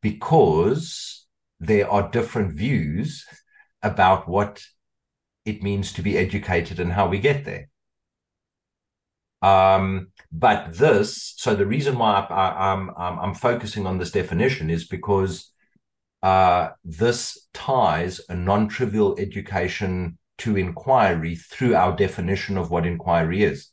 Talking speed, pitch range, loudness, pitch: 125 wpm, 90-105 Hz, -22 LUFS, 95 Hz